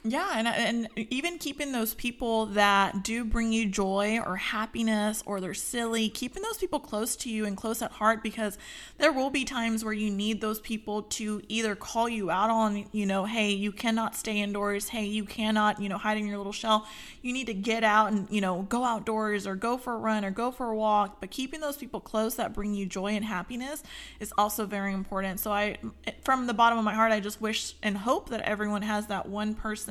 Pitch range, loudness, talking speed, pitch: 205-230 Hz, -29 LUFS, 230 wpm, 220 Hz